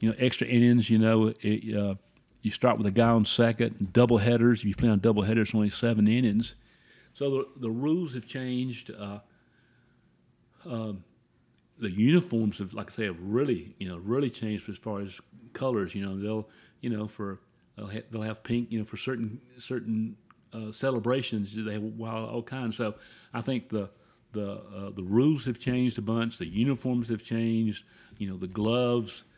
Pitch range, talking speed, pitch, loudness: 105-120 Hz, 190 wpm, 115 Hz, -28 LUFS